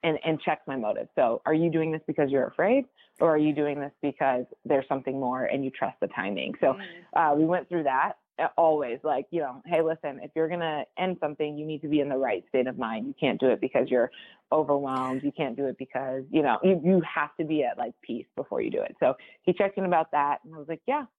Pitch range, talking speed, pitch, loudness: 140-165 Hz, 260 wpm, 155 Hz, -27 LUFS